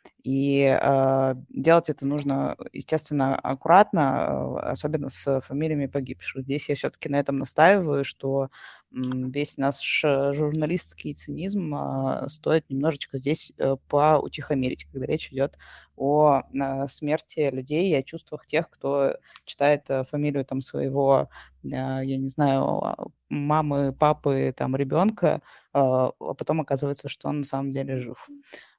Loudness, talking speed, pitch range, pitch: -25 LUFS, 115 wpm, 135-150 Hz, 140 Hz